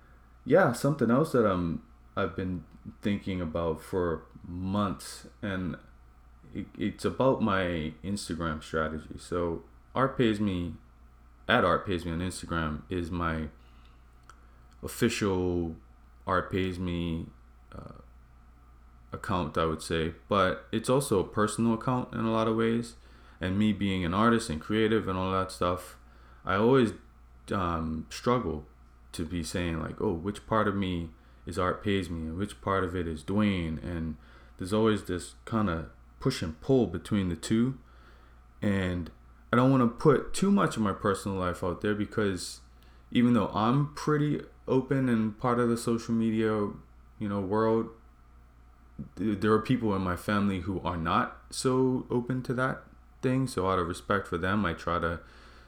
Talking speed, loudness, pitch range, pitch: 160 wpm, -29 LUFS, 75-110 Hz, 90 Hz